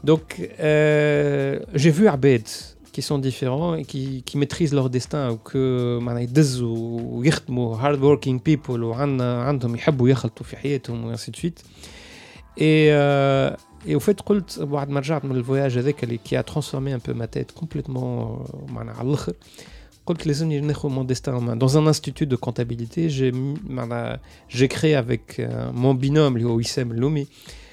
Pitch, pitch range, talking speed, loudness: 135 Hz, 120-145 Hz, 160 wpm, -22 LUFS